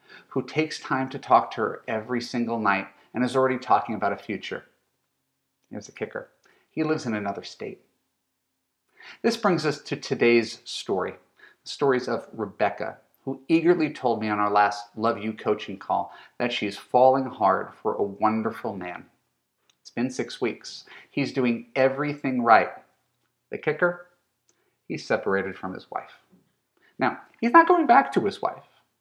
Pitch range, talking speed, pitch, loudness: 110-155 Hz, 160 wpm, 130 Hz, -25 LUFS